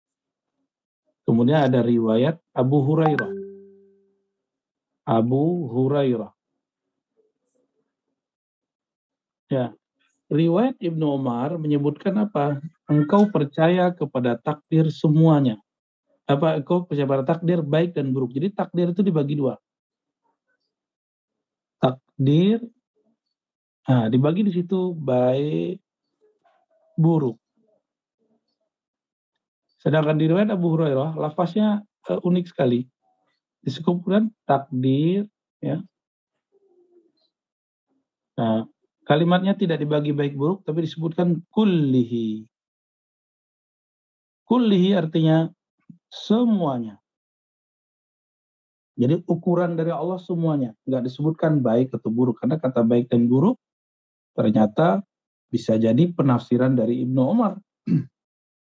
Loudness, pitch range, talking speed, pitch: -22 LUFS, 135-200 Hz, 85 wpm, 160 Hz